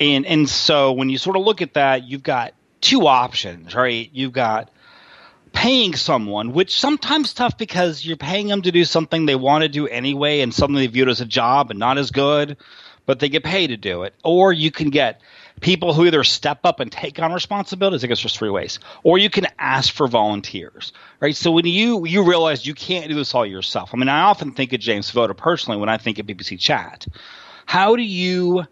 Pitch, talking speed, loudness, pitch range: 145 Hz, 220 wpm, -18 LUFS, 130-180 Hz